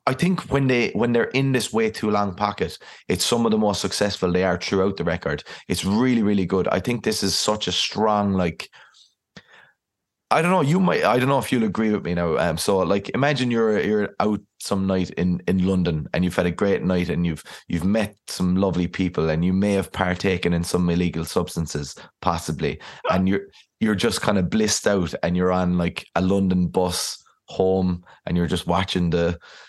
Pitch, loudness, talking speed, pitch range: 95 Hz, -22 LUFS, 210 wpm, 90-105 Hz